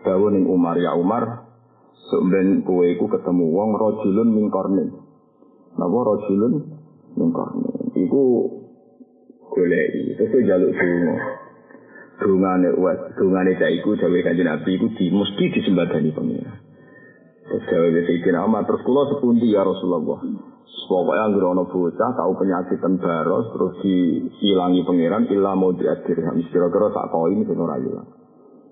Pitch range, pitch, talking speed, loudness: 90-120 Hz, 95 Hz, 130 wpm, -20 LUFS